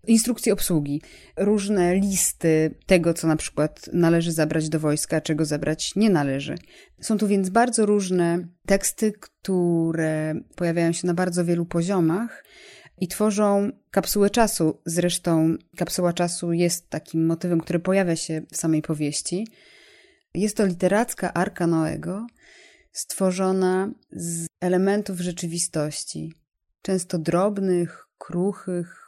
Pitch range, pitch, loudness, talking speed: 165-200 Hz, 175 Hz, -23 LUFS, 120 wpm